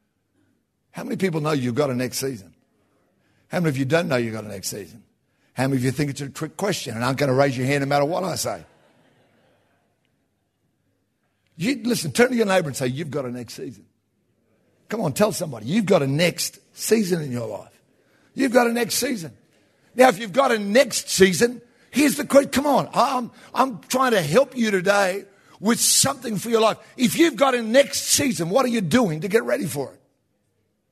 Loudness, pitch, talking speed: -21 LUFS, 185 Hz, 215 wpm